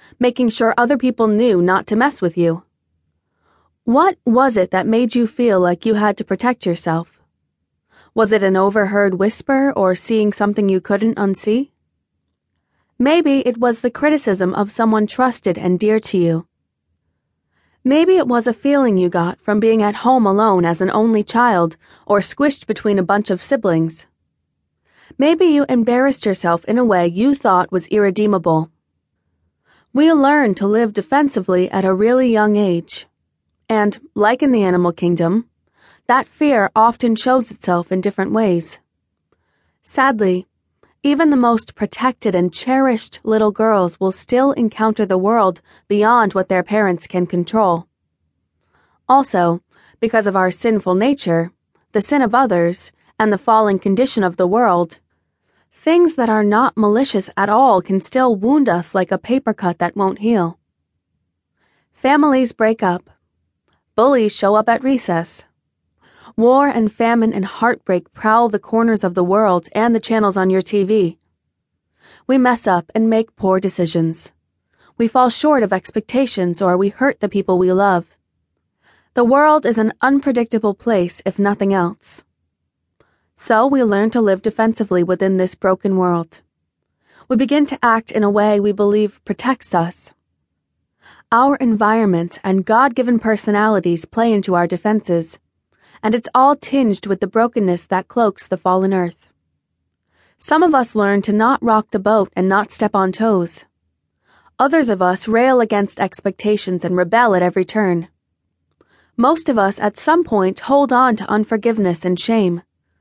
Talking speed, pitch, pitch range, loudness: 155 wpm, 210 Hz, 185-240 Hz, -16 LUFS